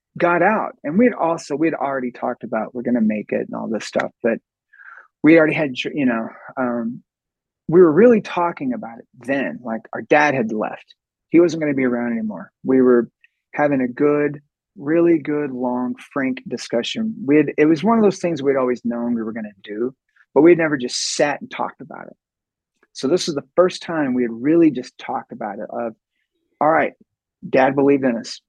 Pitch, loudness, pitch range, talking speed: 145 Hz, -19 LUFS, 125-175 Hz, 200 wpm